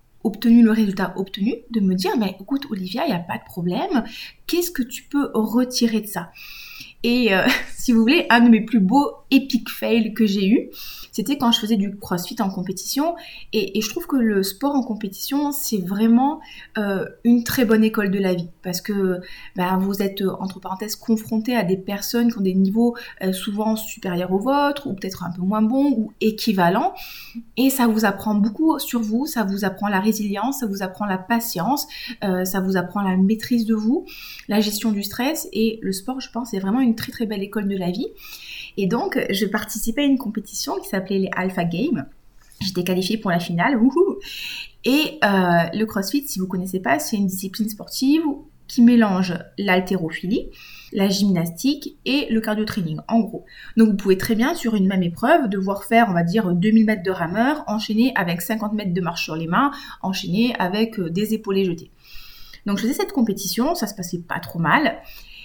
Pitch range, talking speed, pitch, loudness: 195-240 Hz, 205 wpm, 215 Hz, -21 LUFS